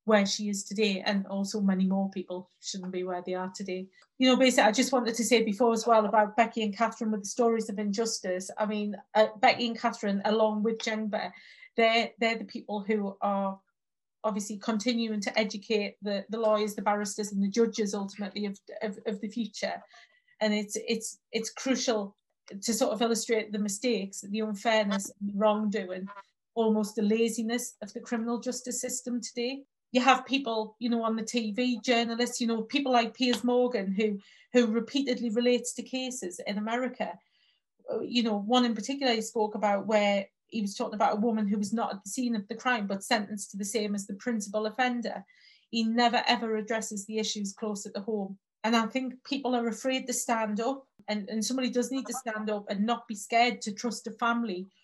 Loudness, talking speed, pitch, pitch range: -29 LUFS, 200 wpm, 220 Hz, 210-240 Hz